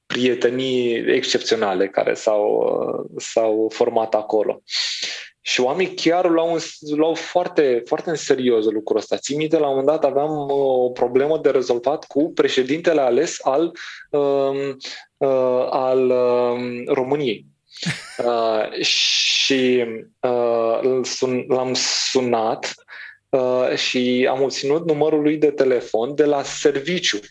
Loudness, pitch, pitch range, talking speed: -20 LUFS, 130 Hz, 125-155 Hz, 115 wpm